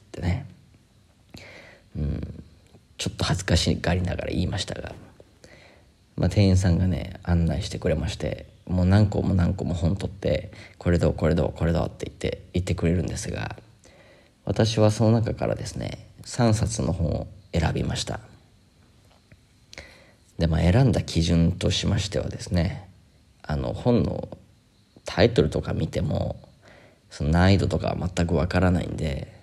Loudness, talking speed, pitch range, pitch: -25 LUFS, 280 characters per minute, 85-105 Hz, 90 Hz